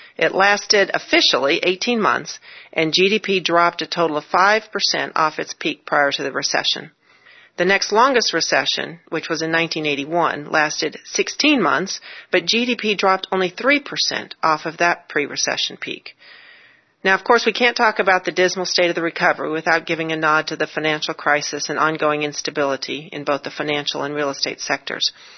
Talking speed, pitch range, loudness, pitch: 175 wpm, 155-205 Hz, -18 LUFS, 170 Hz